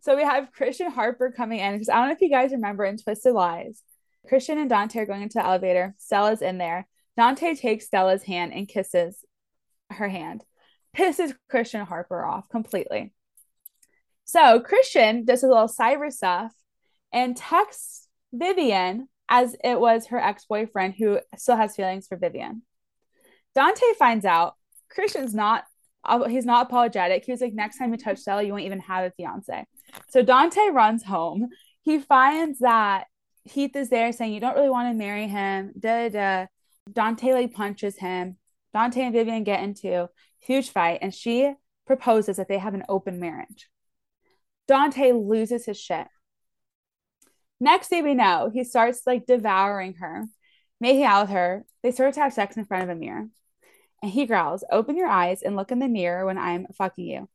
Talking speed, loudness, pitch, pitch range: 180 wpm, -23 LUFS, 225 Hz, 195-260 Hz